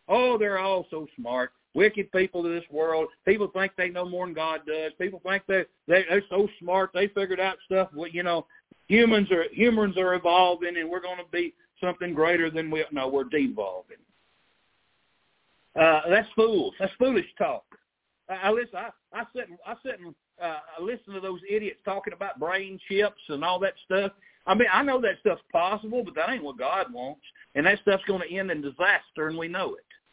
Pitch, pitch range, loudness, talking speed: 190 Hz, 175-205 Hz, -26 LUFS, 205 wpm